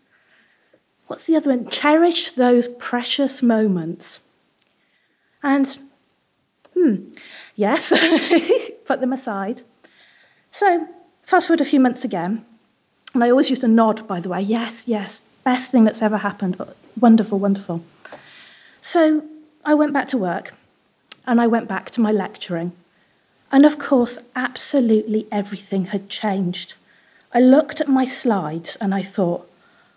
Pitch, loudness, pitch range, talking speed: 245 Hz, -19 LUFS, 210-290 Hz, 135 wpm